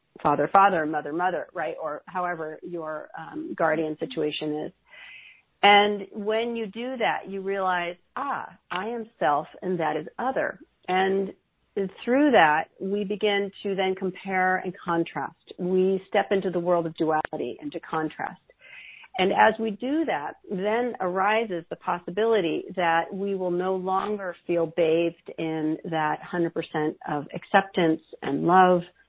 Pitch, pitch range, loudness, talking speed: 185 Hz, 165-200 Hz, -26 LUFS, 145 wpm